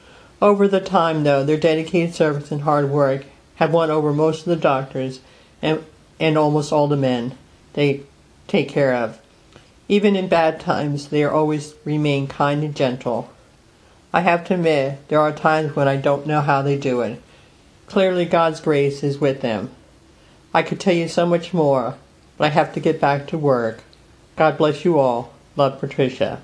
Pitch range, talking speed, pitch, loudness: 140-165 Hz, 180 wpm, 150 Hz, -19 LUFS